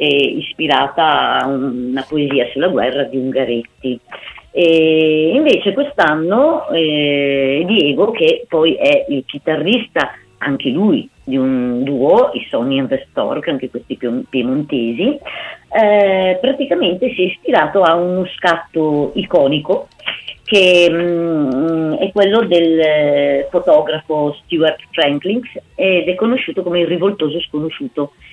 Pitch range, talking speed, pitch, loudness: 145-200 Hz, 120 wpm, 165 Hz, -15 LUFS